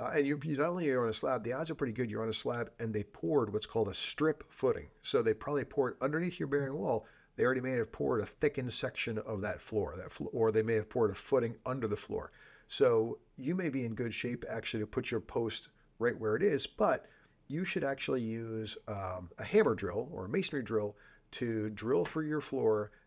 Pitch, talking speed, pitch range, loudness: 125 Hz, 240 wpm, 110-150 Hz, -34 LUFS